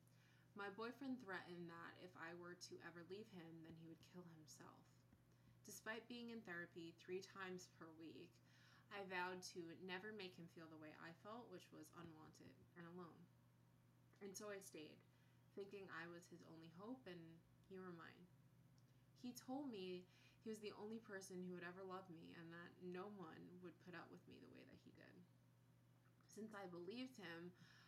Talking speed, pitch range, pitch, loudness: 185 wpm, 160-195 Hz, 175 Hz, -57 LUFS